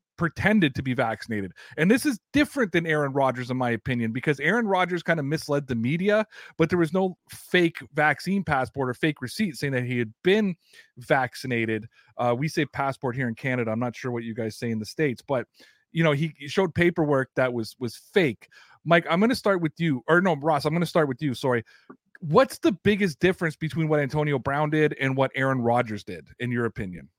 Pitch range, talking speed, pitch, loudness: 125-170 Hz, 220 wpm, 150 Hz, -25 LUFS